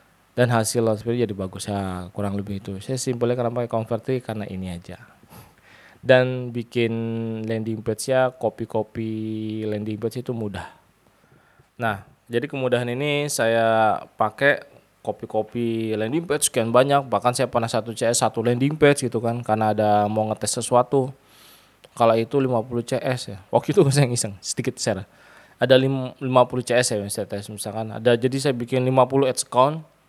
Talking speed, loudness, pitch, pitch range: 160 wpm, -22 LUFS, 115 Hz, 110-125 Hz